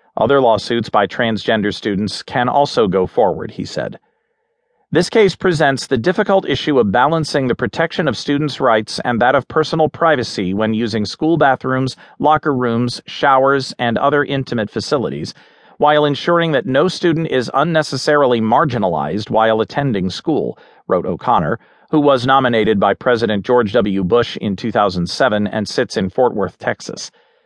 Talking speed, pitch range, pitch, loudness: 150 wpm, 110-155 Hz, 130 Hz, -16 LUFS